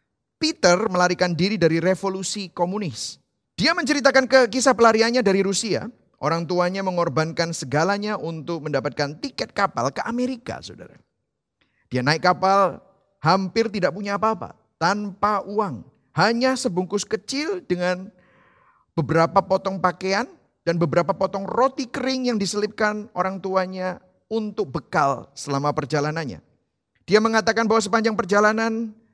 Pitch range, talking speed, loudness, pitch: 175-225 Hz, 120 wpm, -22 LUFS, 195 Hz